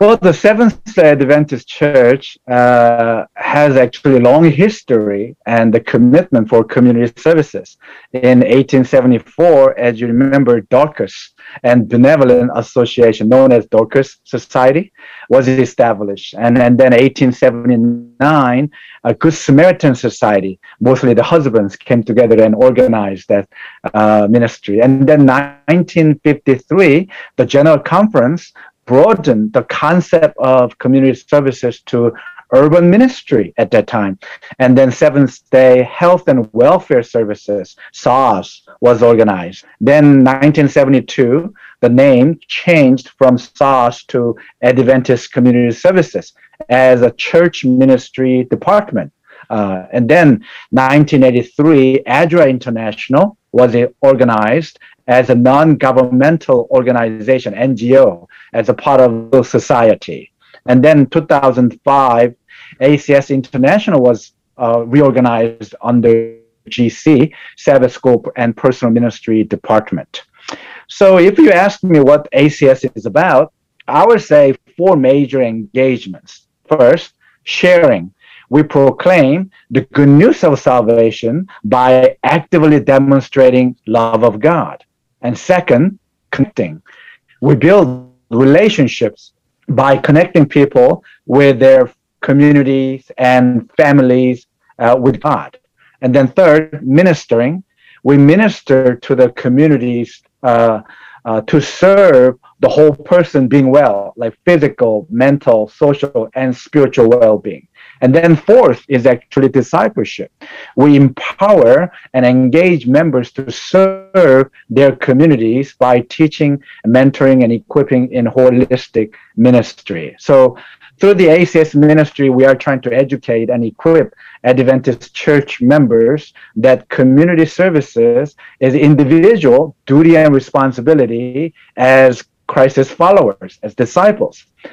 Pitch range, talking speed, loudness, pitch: 120-150 Hz, 115 wpm, -10 LUFS, 130 Hz